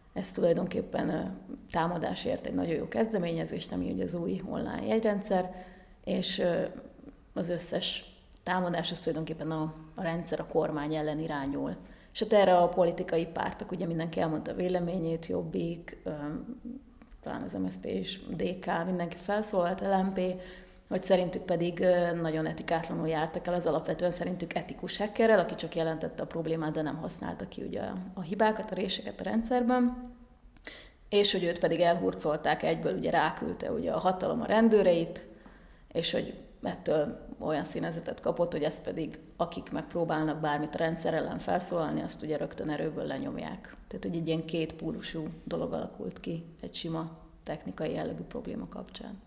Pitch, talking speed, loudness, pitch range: 175 Hz, 150 wpm, -31 LUFS, 165-195 Hz